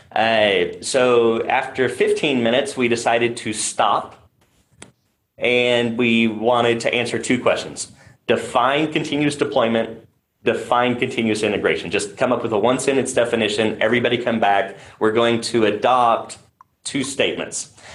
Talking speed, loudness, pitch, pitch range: 130 wpm, -19 LUFS, 120 Hz, 115-125 Hz